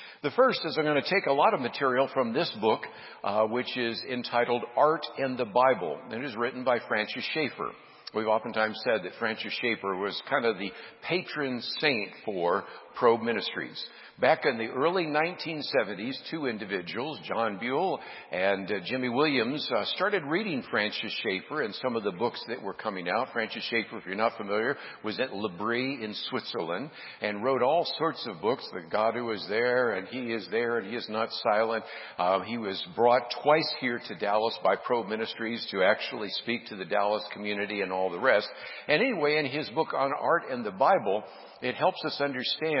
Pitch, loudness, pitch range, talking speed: 120 Hz, -29 LUFS, 110-140 Hz, 195 wpm